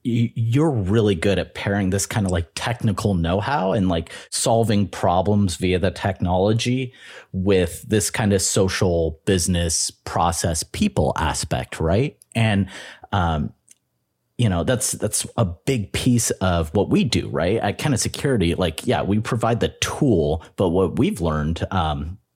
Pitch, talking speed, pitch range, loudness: 100 Hz, 155 wpm, 90-110 Hz, -21 LUFS